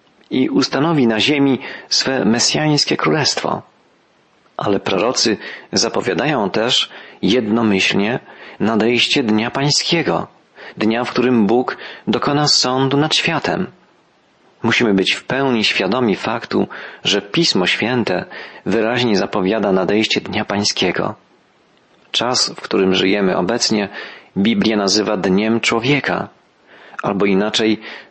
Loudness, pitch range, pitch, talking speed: -16 LUFS, 105-135 Hz, 115 Hz, 100 wpm